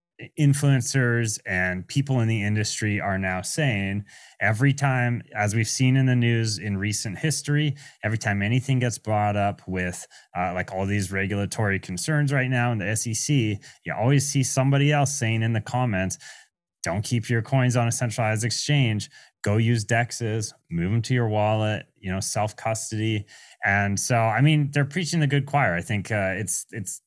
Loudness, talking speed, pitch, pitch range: -24 LUFS, 180 wpm, 115 Hz, 105-130 Hz